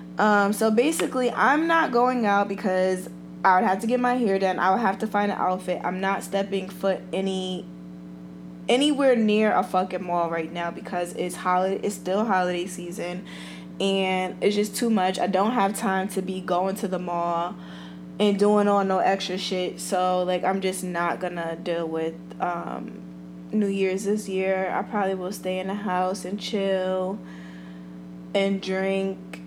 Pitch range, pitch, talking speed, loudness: 175-200 Hz, 185 Hz, 175 wpm, -24 LUFS